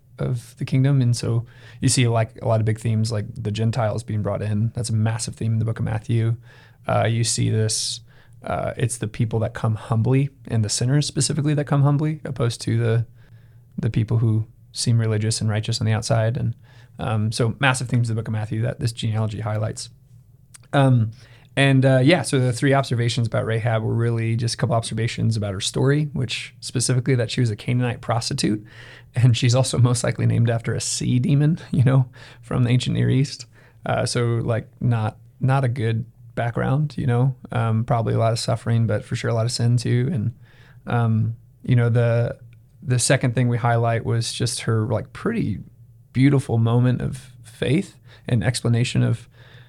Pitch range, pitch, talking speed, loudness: 115-125 Hz, 120 Hz, 195 wpm, -22 LUFS